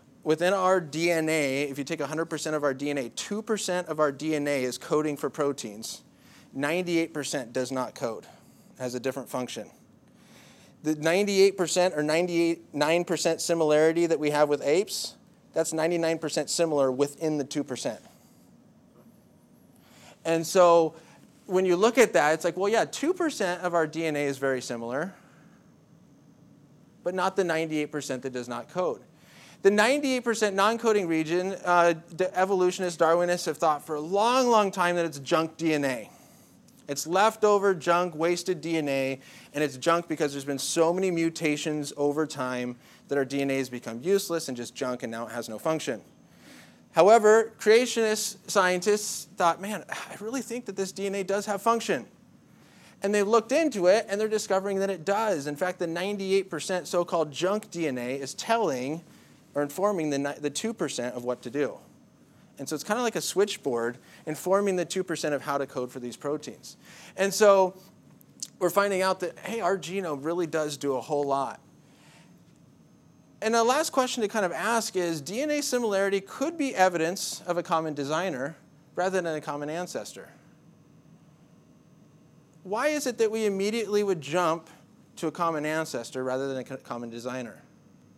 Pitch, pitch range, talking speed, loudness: 165 Hz, 145-195 Hz, 160 wpm, -27 LUFS